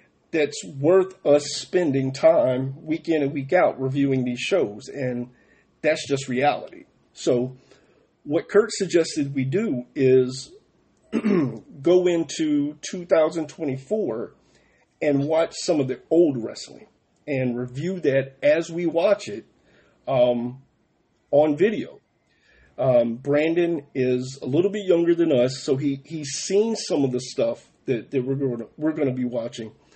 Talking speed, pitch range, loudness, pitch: 140 wpm, 130-165 Hz, -23 LUFS, 145 Hz